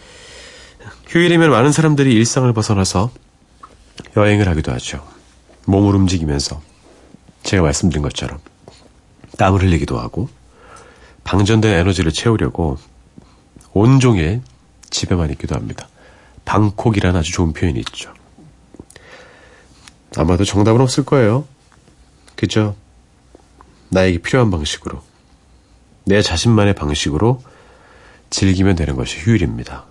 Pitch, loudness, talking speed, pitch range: 100 Hz, -16 LUFS, 260 characters per minute, 85-120 Hz